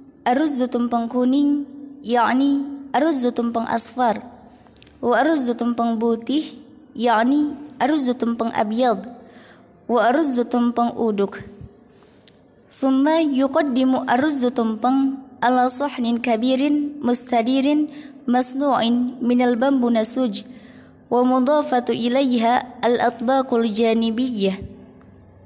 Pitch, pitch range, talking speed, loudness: 245 Hz, 235-275 Hz, 80 wpm, -19 LUFS